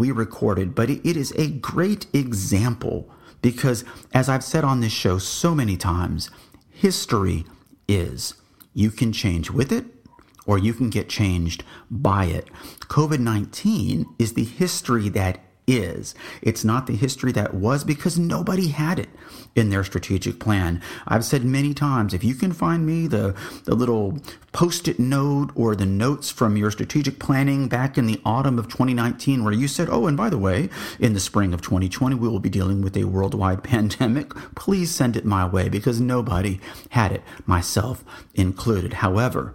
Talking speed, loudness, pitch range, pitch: 175 wpm, -22 LUFS, 100-135 Hz, 115 Hz